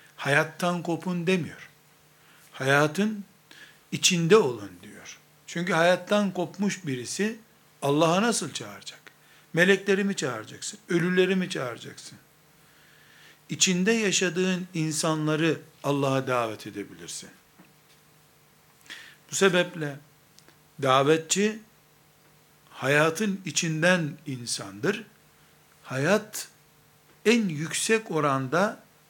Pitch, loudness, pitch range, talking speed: 160 Hz, -25 LUFS, 150-185 Hz, 75 wpm